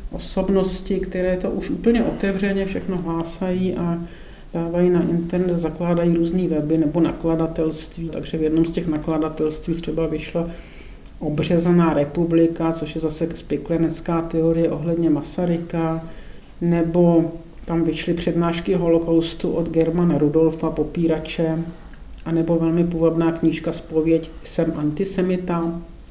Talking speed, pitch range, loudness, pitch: 115 wpm, 160-170 Hz, -21 LUFS, 165 Hz